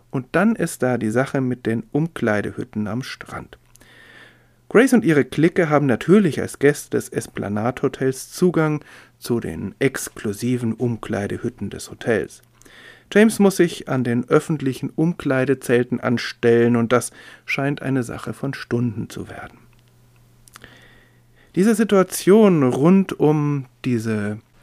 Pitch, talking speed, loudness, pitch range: 130 Hz, 125 wpm, -20 LUFS, 120-150 Hz